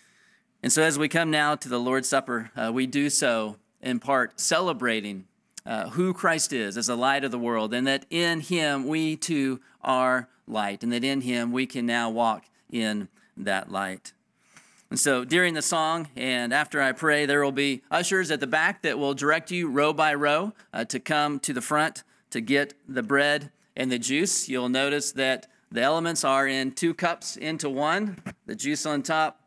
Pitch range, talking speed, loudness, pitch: 125-155 Hz, 200 wpm, -25 LUFS, 140 Hz